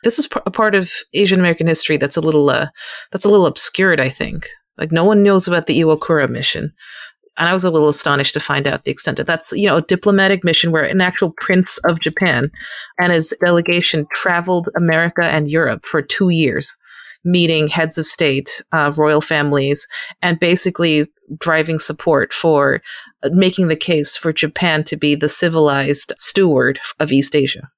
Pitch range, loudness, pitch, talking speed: 150-180 Hz, -15 LUFS, 165 Hz, 185 wpm